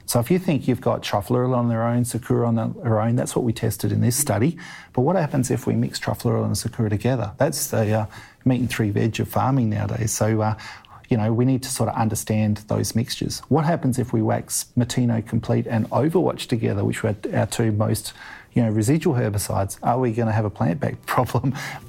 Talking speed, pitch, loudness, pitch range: 220 wpm, 115 Hz, -22 LUFS, 110-125 Hz